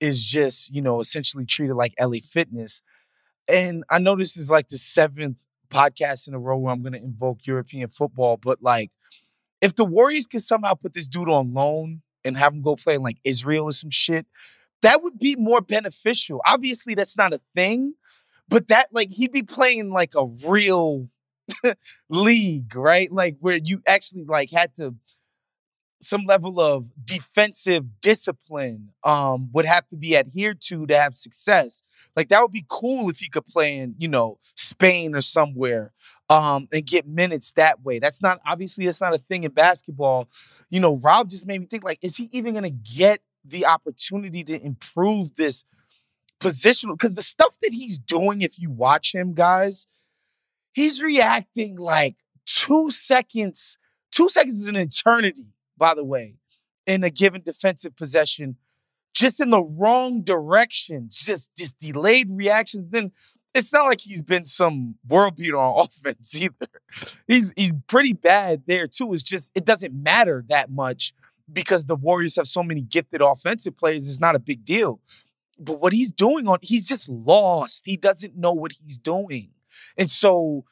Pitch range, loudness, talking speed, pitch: 140-200 Hz, -20 LUFS, 175 wpm, 170 Hz